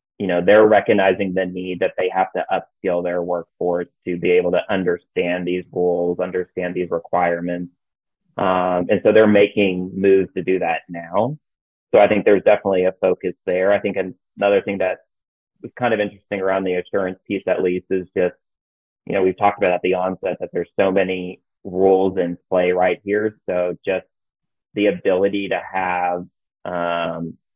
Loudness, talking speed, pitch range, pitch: -19 LUFS, 180 wpm, 90-95 Hz, 90 Hz